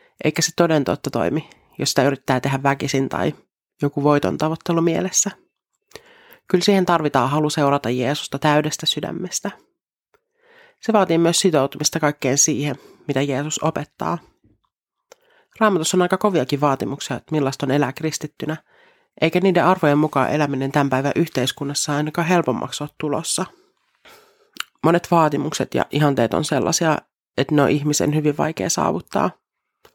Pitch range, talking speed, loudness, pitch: 140-180 Hz, 135 wpm, -20 LUFS, 150 Hz